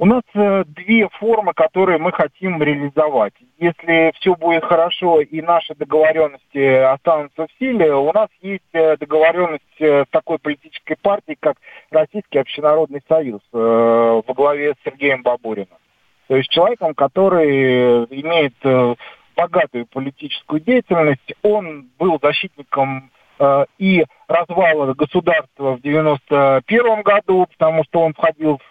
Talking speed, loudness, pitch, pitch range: 120 wpm, -16 LUFS, 155 Hz, 140-175 Hz